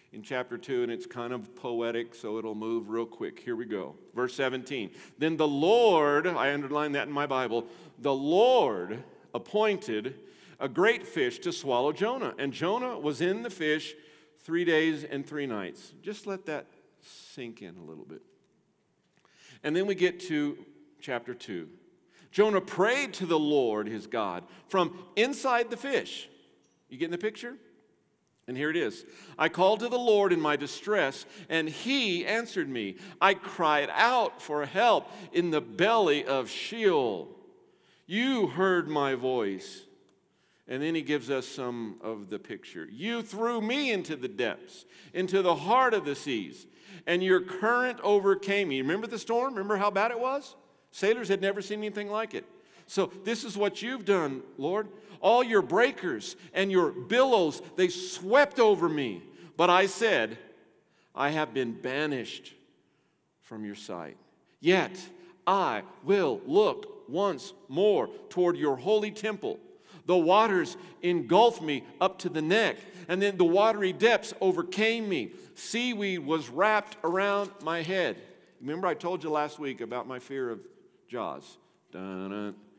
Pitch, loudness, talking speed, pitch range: 185 Hz, -28 LUFS, 160 wpm, 145-220 Hz